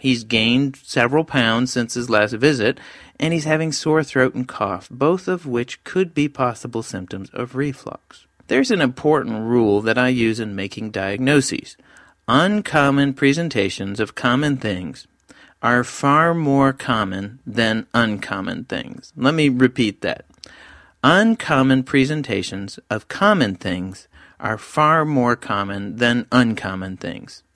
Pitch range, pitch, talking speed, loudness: 110-140 Hz, 125 Hz, 135 wpm, -19 LUFS